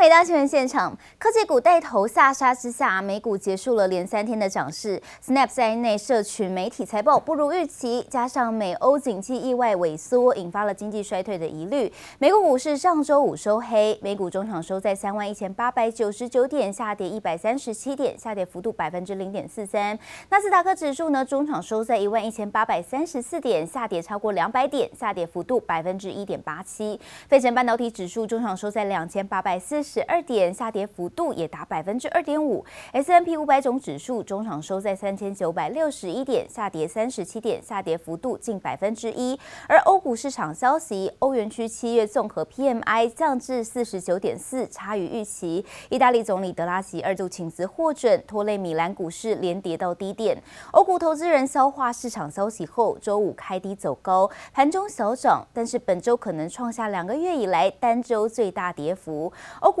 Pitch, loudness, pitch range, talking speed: 220 Hz, -24 LUFS, 195-260 Hz, 310 characters per minute